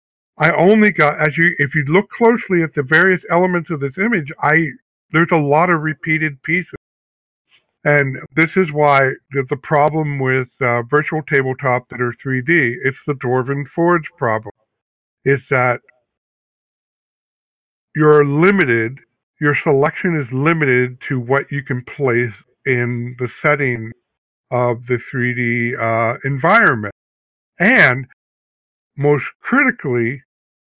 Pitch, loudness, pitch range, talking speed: 140 Hz, -16 LUFS, 125-160 Hz, 125 wpm